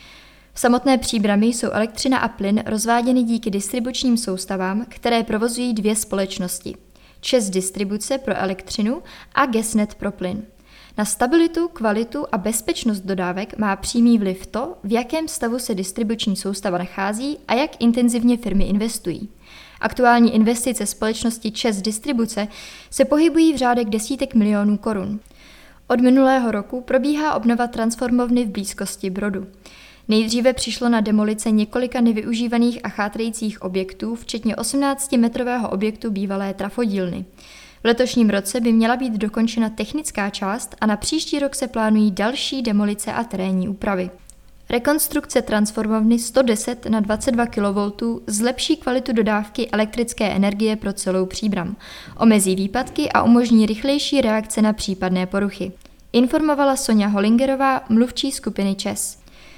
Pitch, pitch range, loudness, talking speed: 225 Hz, 205-245 Hz, -20 LUFS, 130 wpm